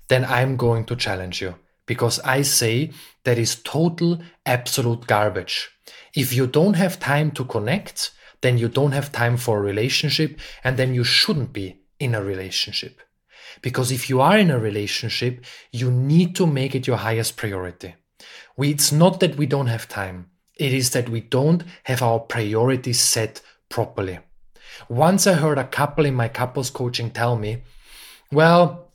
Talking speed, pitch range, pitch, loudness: 170 wpm, 115-145 Hz, 125 Hz, -21 LUFS